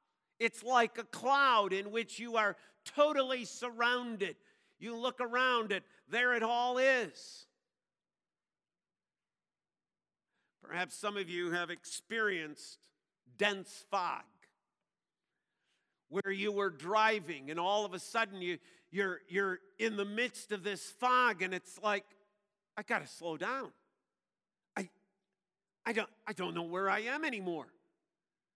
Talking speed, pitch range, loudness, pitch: 130 wpm, 190-230 Hz, -35 LUFS, 205 Hz